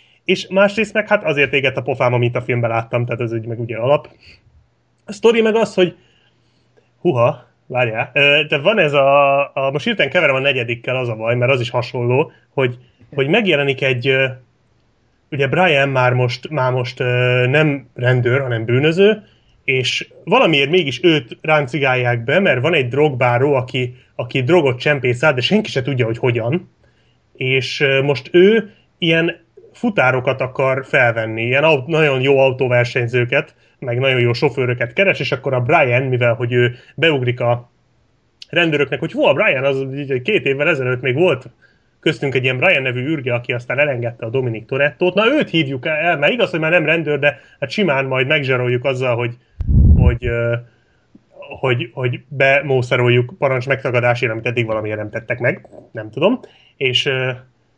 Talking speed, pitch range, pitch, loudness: 160 wpm, 125-150 Hz, 130 Hz, -16 LUFS